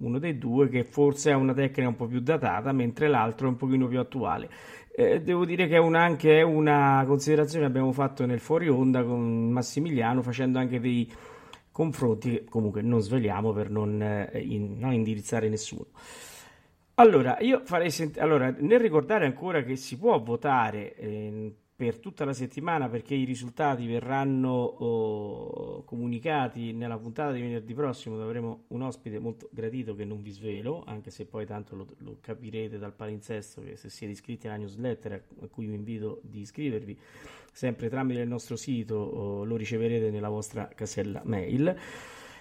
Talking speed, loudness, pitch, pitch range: 170 wpm, -27 LUFS, 120 Hz, 110-140 Hz